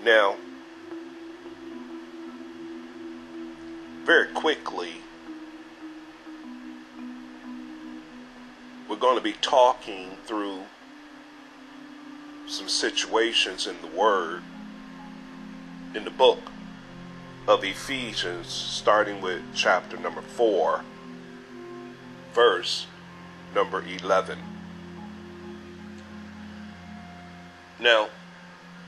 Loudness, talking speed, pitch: -25 LUFS, 60 wpm, 105 Hz